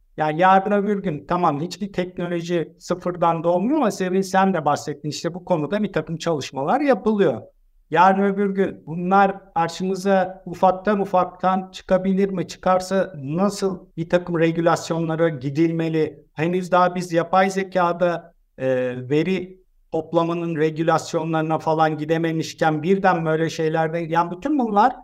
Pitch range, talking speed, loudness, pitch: 160-190 Hz, 125 wpm, -21 LUFS, 175 Hz